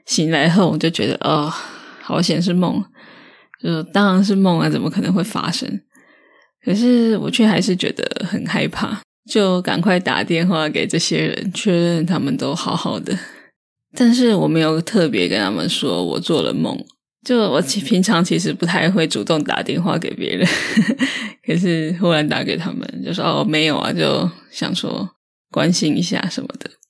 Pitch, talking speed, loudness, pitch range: 185 Hz, 245 characters per minute, -18 LUFS, 165-220 Hz